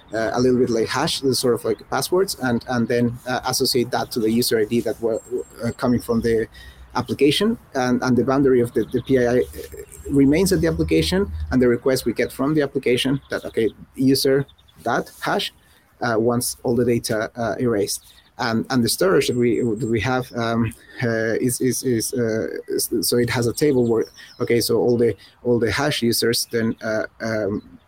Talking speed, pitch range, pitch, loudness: 200 wpm, 115-135 Hz, 120 Hz, -21 LUFS